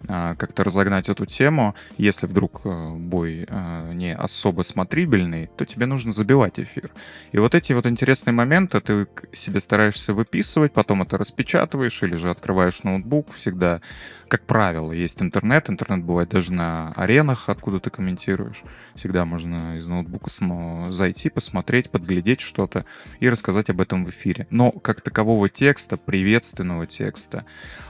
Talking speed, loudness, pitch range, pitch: 140 wpm, -22 LUFS, 90-115 Hz, 95 Hz